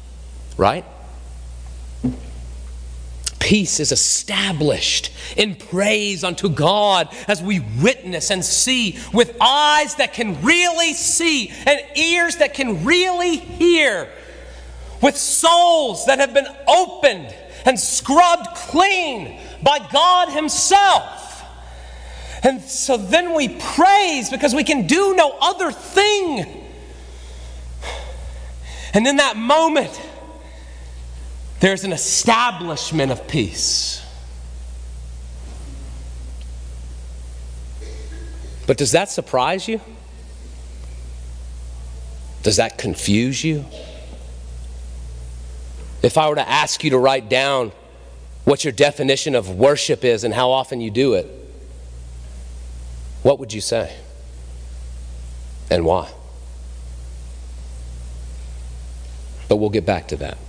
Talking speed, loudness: 100 wpm, -17 LUFS